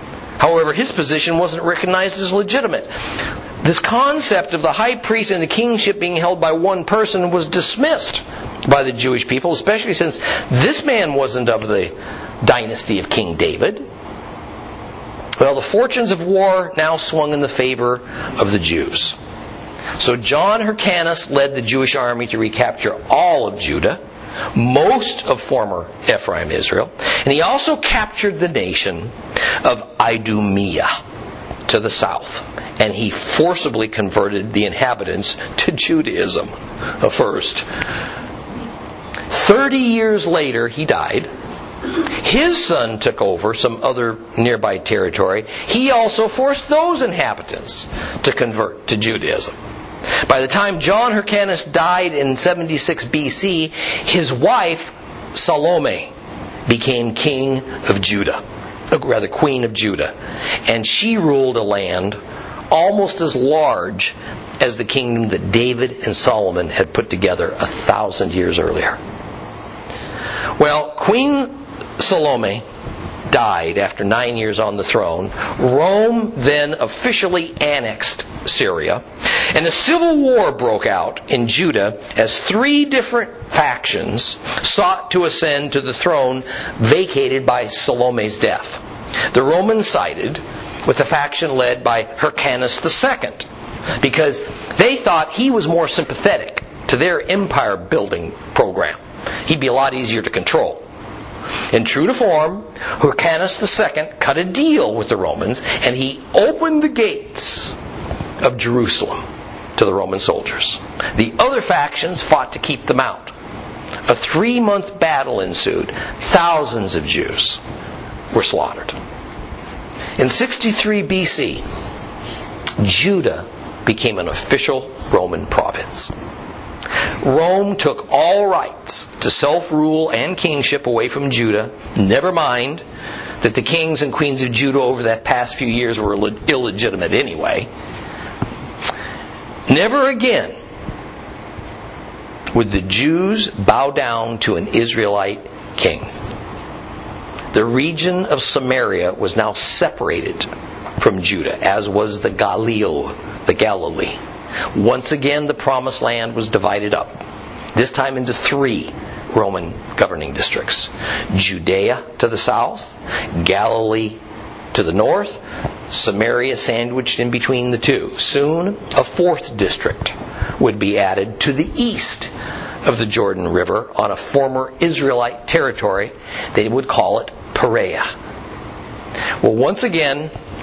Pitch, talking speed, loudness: 155 Hz, 125 wpm, -16 LUFS